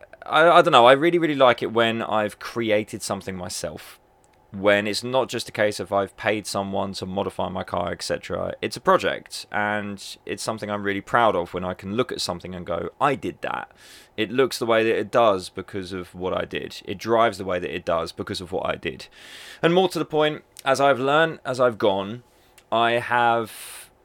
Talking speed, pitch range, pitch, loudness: 215 wpm, 95-120 Hz, 105 Hz, -23 LUFS